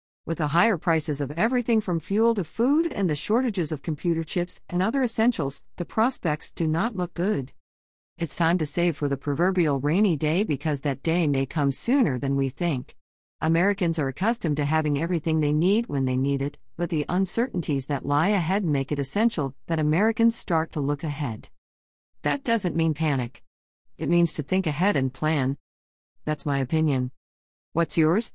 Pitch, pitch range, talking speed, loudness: 160 Hz, 140-180 Hz, 180 wpm, -25 LUFS